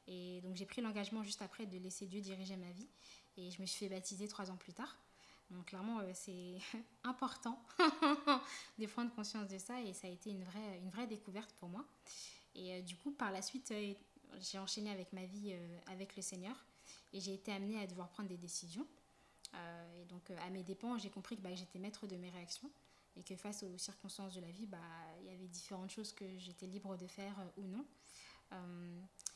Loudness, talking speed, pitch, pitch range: -46 LUFS, 200 wpm, 195 Hz, 185-215 Hz